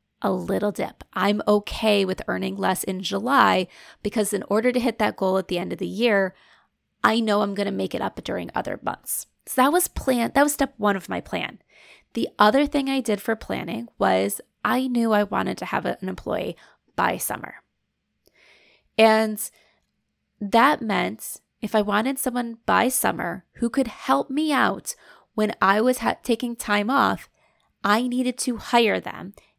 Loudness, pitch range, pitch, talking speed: -23 LUFS, 205-250 Hz, 220 Hz, 180 wpm